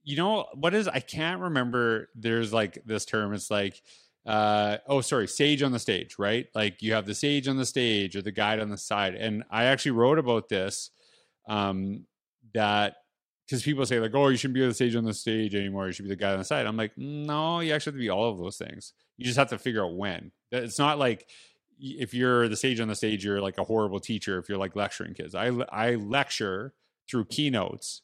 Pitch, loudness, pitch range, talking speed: 115 Hz, -28 LUFS, 105-130 Hz, 235 wpm